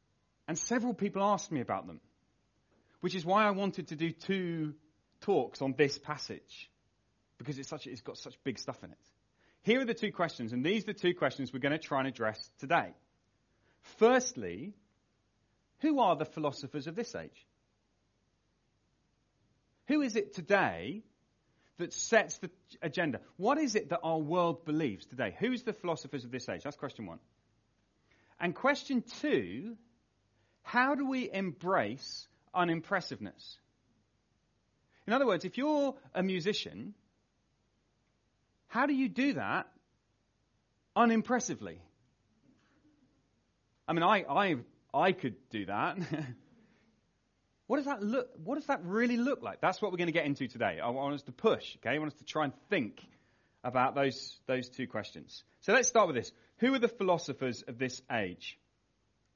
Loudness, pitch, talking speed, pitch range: -33 LUFS, 165 Hz, 160 wpm, 130-215 Hz